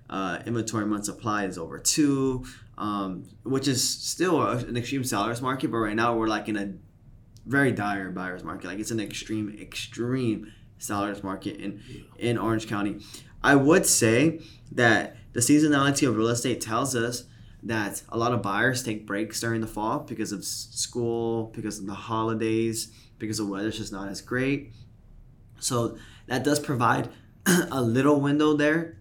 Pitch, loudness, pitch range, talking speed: 115 Hz, -26 LUFS, 105-125 Hz, 165 wpm